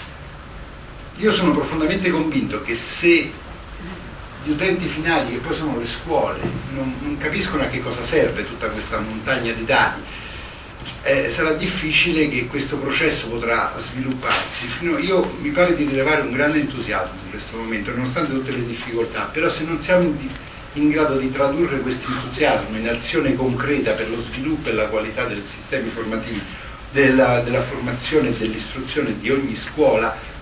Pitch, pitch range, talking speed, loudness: 135 Hz, 115-155 Hz, 155 wpm, -20 LUFS